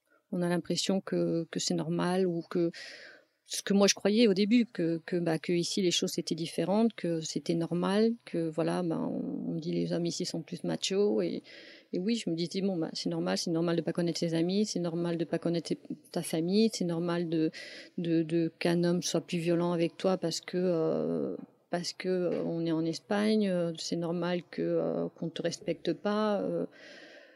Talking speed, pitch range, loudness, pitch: 215 wpm, 165-195 Hz, -31 LUFS, 175 Hz